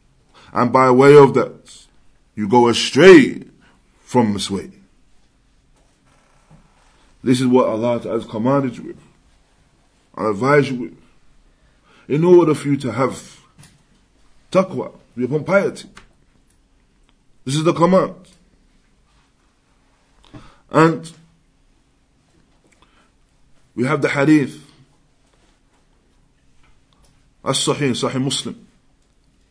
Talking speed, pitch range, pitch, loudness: 90 wpm, 120-145 Hz, 135 Hz, -16 LUFS